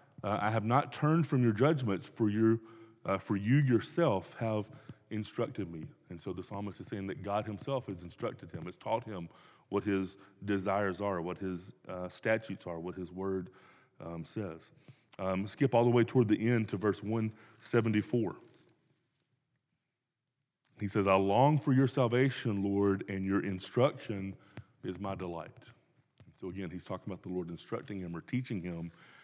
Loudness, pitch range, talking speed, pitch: -33 LUFS, 95-120 Hz, 170 wpm, 105 Hz